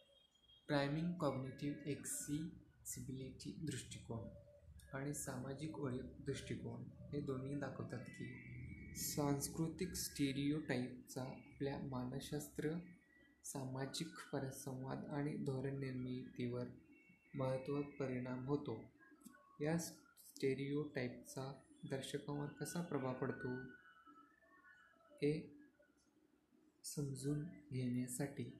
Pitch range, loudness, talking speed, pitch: 130-160 Hz, -46 LUFS, 65 wpm, 140 Hz